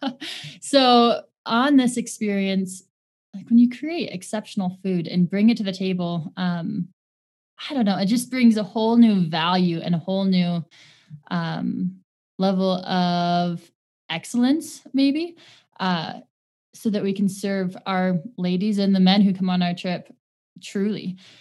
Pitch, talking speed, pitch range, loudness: 190 Hz, 150 wpm, 180-230 Hz, -22 LUFS